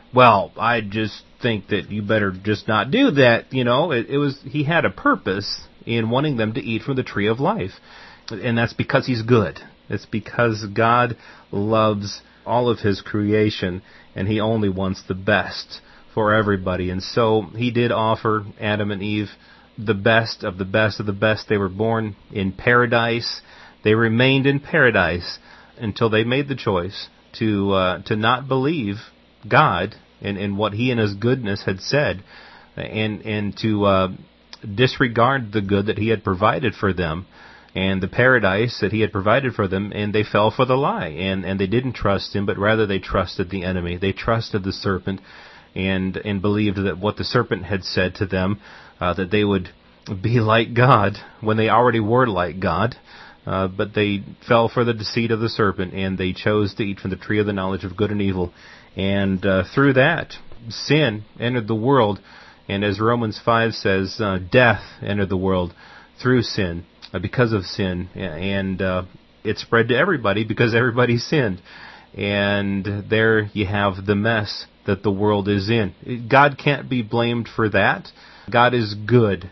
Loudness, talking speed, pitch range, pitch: -20 LUFS, 185 wpm, 100-115 Hz, 105 Hz